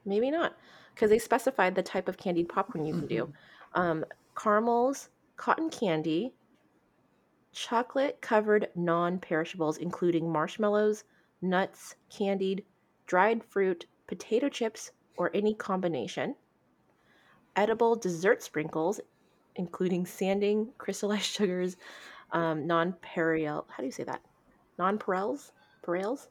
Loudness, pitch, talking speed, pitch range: -30 LUFS, 190 Hz, 110 wpm, 170-215 Hz